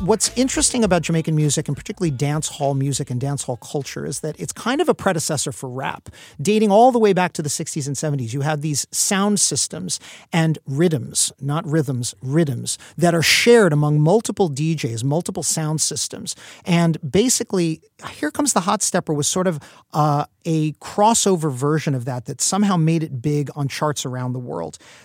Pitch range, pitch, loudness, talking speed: 145-185 Hz, 155 Hz, -20 LUFS, 185 wpm